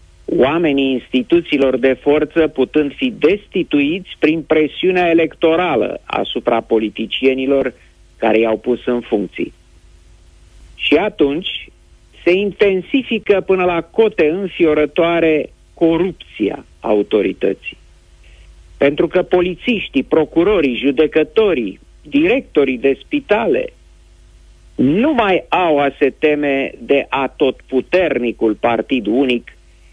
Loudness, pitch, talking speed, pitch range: -16 LUFS, 145 Hz, 95 wpm, 115-180 Hz